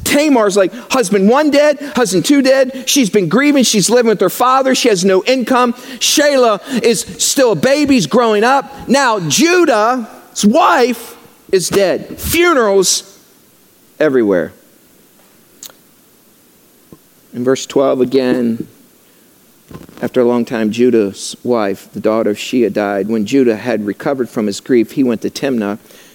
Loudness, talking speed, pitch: -13 LUFS, 140 wpm, 225 Hz